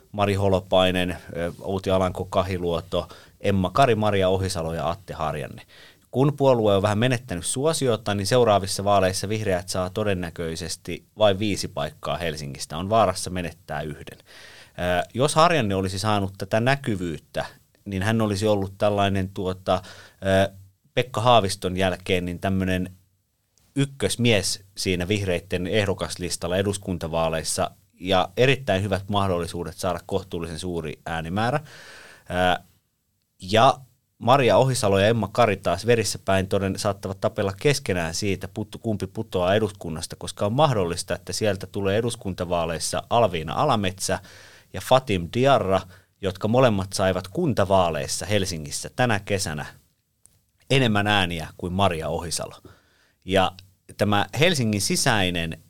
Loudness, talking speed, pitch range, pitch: -23 LUFS, 115 wpm, 90-105 Hz, 95 Hz